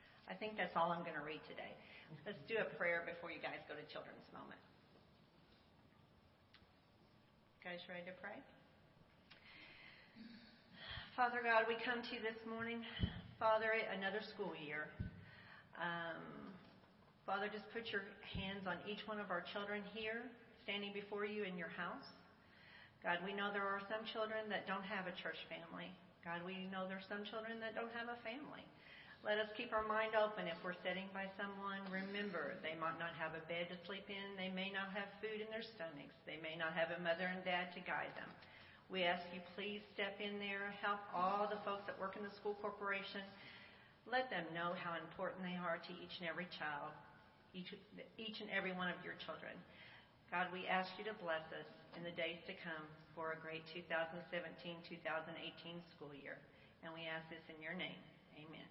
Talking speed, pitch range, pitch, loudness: 185 wpm, 170-210 Hz, 190 Hz, -45 LUFS